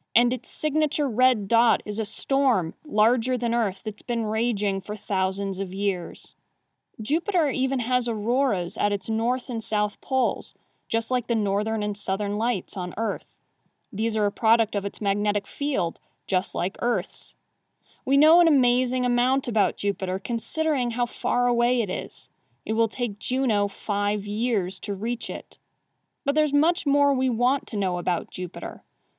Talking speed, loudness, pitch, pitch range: 165 wpm, -25 LUFS, 225 Hz, 200-255 Hz